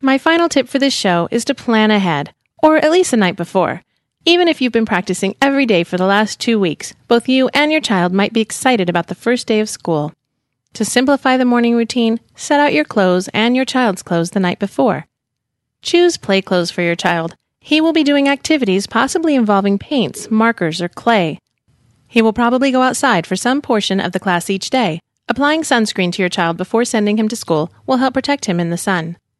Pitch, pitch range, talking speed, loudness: 220 Hz, 180-260 Hz, 215 wpm, -15 LUFS